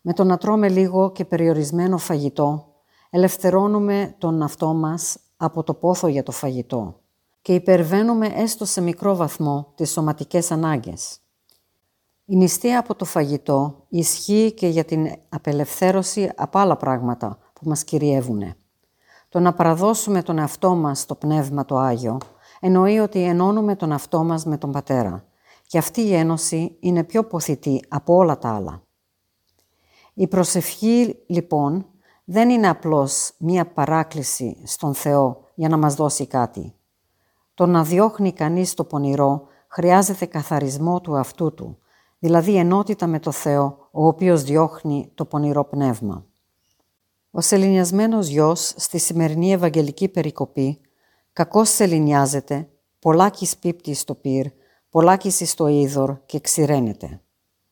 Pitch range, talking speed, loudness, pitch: 140-180 Hz, 135 wpm, -20 LUFS, 160 Hz